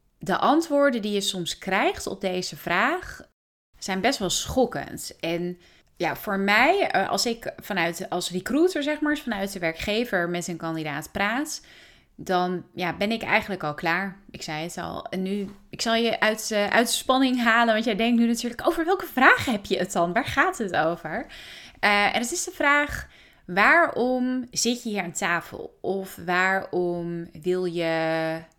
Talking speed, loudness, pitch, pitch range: 175 wpm, -24 LUFS, 200 Hz, 175-240 Hz